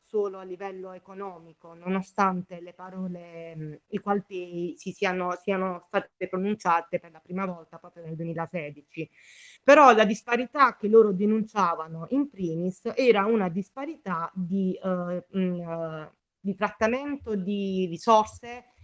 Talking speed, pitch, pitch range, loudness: 130 wpm, 185 Hz, 175-210 Hz, -26 LUFS